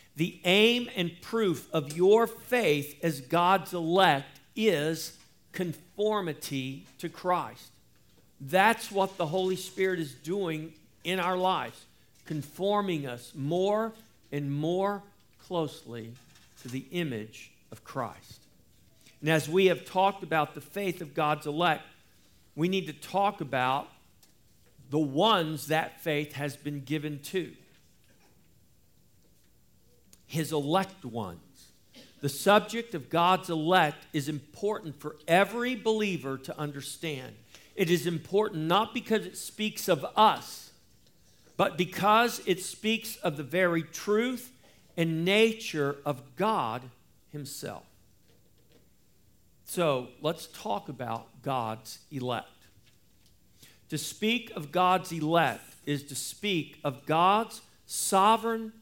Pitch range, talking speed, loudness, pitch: 145-190 Hz, 115 wpm, -29 LUFS, 165 Hz